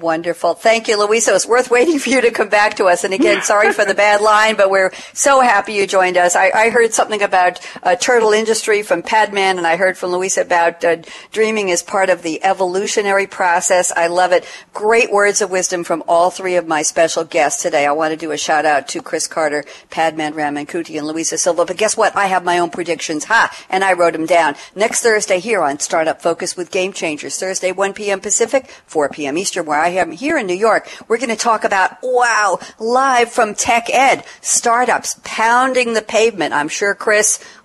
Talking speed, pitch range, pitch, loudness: 210 wpm, 175-220 Hz, 195 Hz, -15 LUFS